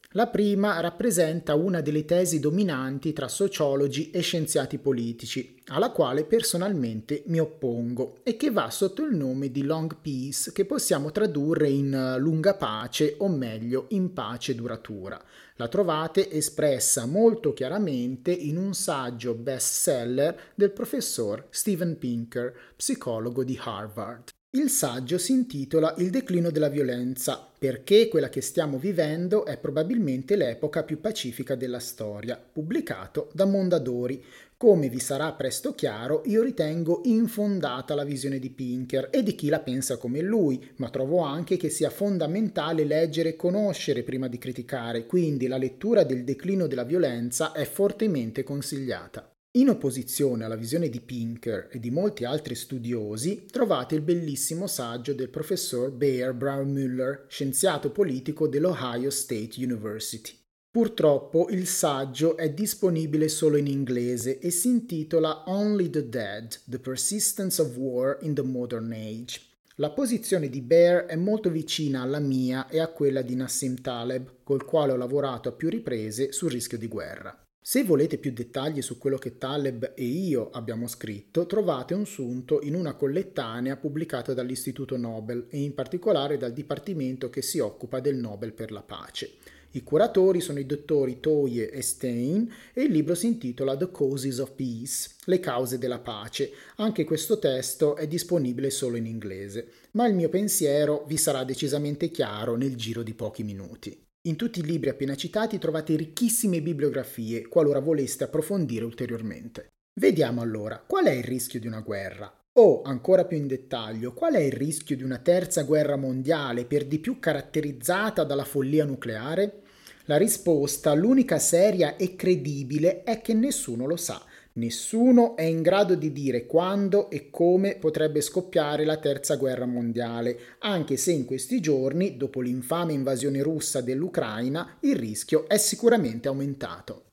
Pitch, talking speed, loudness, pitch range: 145 Hz, 155 wpm, -26 LUFS, 130-175 Hz